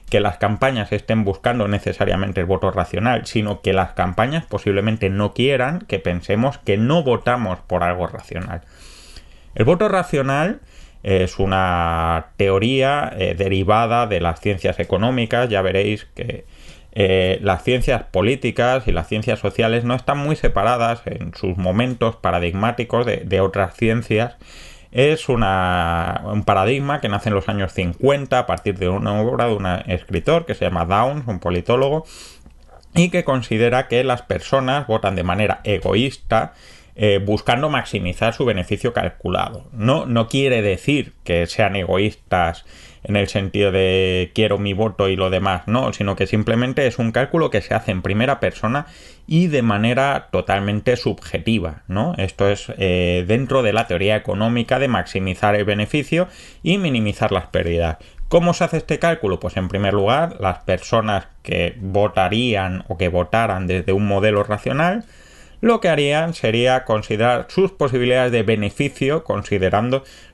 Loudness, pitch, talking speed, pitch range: -19 LUFS, 105 Hz, 150 wpm, 95-125 Hz